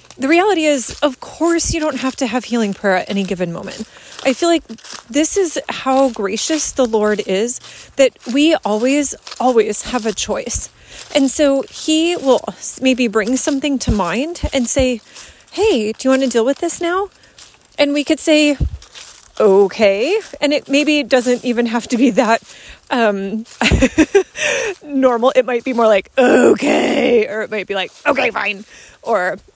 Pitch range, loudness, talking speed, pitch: 225-295 Hz, -16 LUFS, 170 wpm, 260 Hz